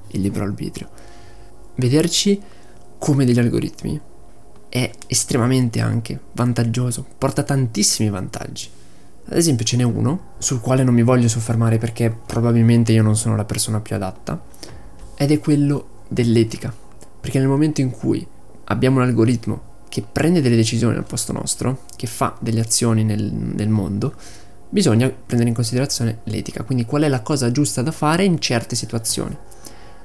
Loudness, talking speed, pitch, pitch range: -19 LUFS, 150 wpm, 120 Hz, 110-130 Hz